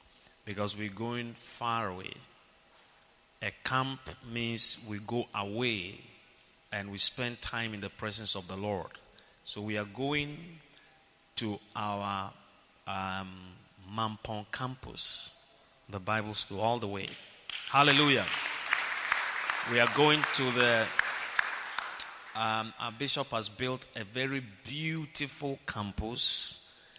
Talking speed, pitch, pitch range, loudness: 115 wpm, 110 Hz, 105-130 Hz, -31 LUFS